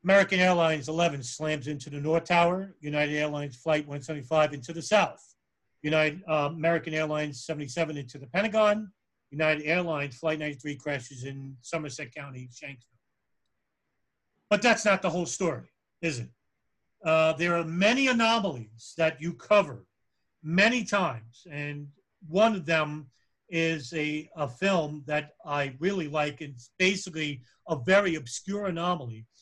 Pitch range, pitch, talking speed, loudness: 145-175 Hz, 155 Hz, 140 wpm, -27 LUFS